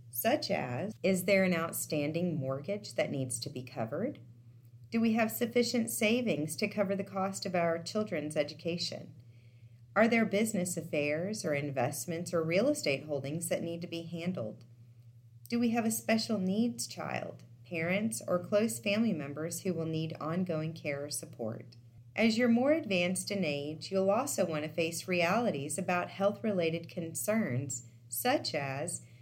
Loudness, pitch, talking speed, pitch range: -33 LUFS, 170 Hz, 160 wpm, 145-200 Hz